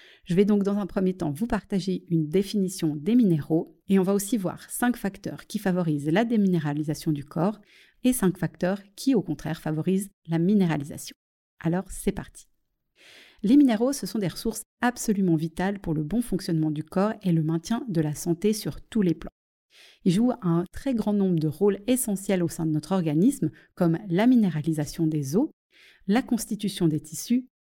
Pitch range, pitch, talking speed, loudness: 165-215 Hz, 190 Hz, 185 wpm, -26 LUFS